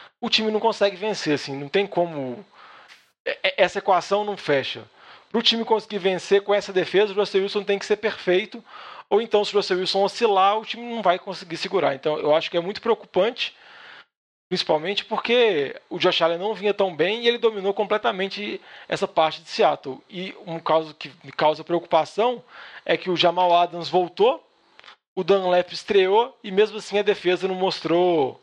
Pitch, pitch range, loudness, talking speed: 195 Hz, 170-210 Hz, -22 LUFS, 185 wpm